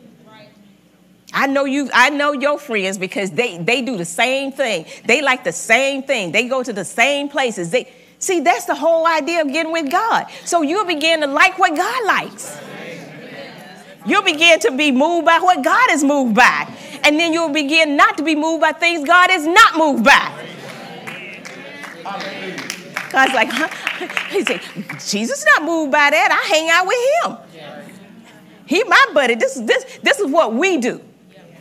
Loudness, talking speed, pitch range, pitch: -15 LUFS, 180 wpm, 235-330 Hz, 285 Hz